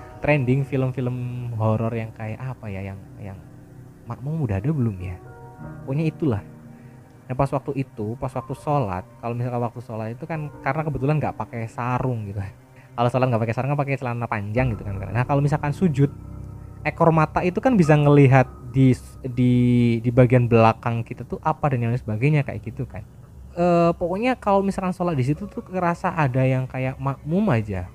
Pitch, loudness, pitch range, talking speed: 130 Hz, -22 LUFS, 115-145 Hz, 180 wpm